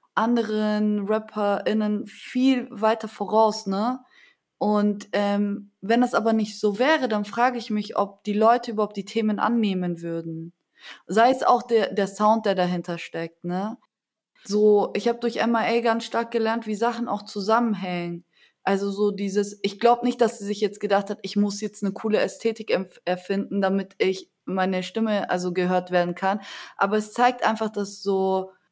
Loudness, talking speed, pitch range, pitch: -24 LUFS, 170 wpm, 195-225 Hz, 210 Hz